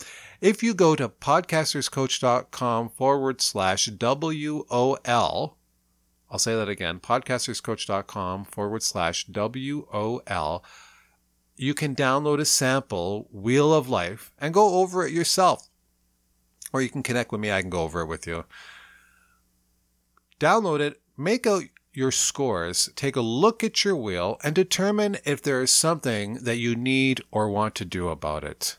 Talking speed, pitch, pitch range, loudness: 150 wpm, 125 Hz, 100-145 Hz, -24 LUFS